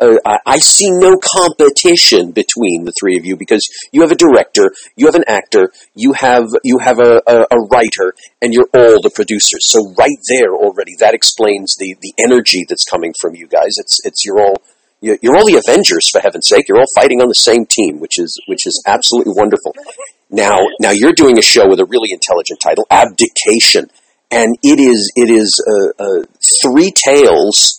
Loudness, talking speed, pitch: -9 LUFS, 195 wpm, 365 Hz